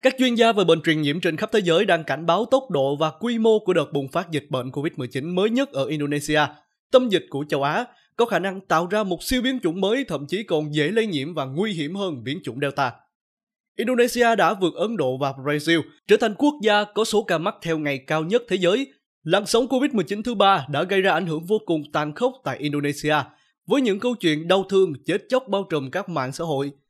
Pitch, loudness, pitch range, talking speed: 170 Hz, -22 LUFS, 150-215 Hz, 245 wpm